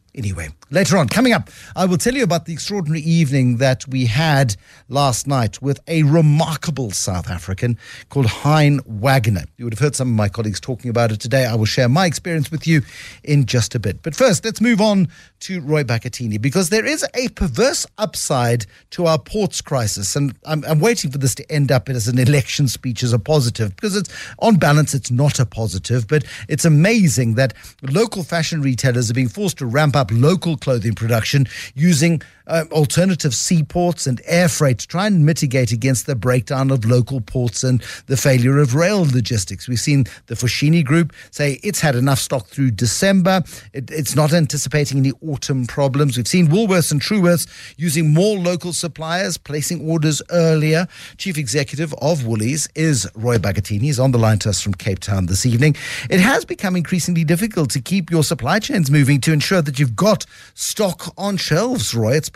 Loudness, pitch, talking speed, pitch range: -17 LUFS, 145 Hz, 195 wpm, 125-165 Hz